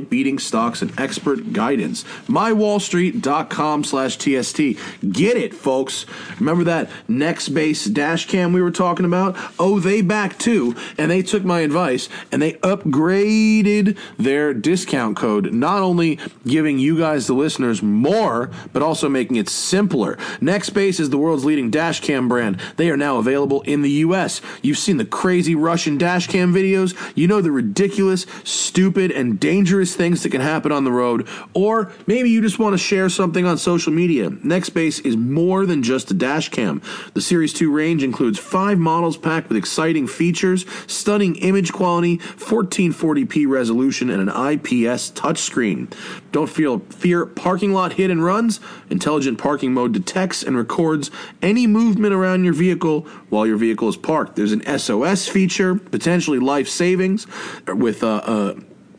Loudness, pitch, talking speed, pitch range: -18 LUFS, 175 Hz, 160 wpm, 150-195 Hz